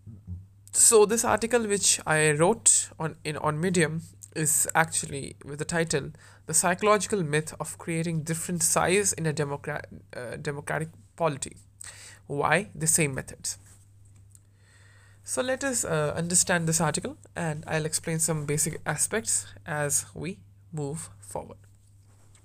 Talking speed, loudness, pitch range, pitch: 130 wpm, -25 LUFS, 100-165 Hz, 150 Hz